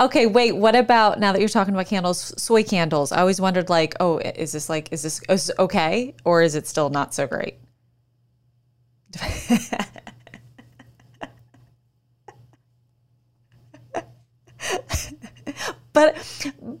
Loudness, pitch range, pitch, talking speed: -21 LUFS, 120-200 Hz, 155 Hz, 120 wpm